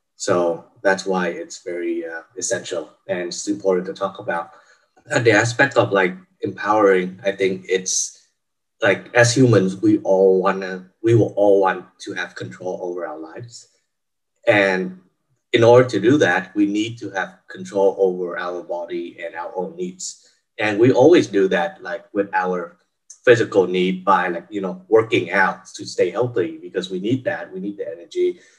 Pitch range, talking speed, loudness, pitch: 95-120 Hz, 175 wpm, -19 LUFS, 95 Hz